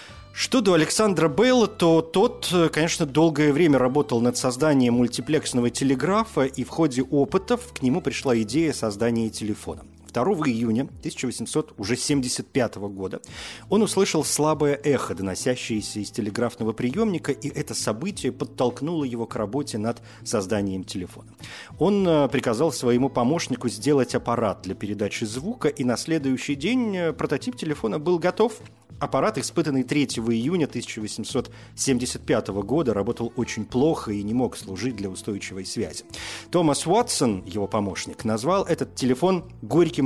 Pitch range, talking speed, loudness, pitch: 115-155 Hz, 130 wpm, -24 LUFS, 130 Hz